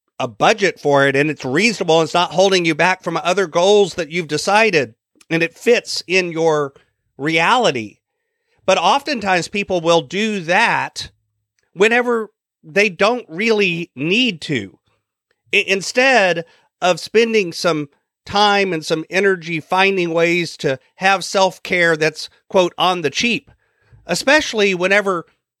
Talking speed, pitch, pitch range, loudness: 135 wpm, 180 Hz, 165-205 Hz, -16 LUFS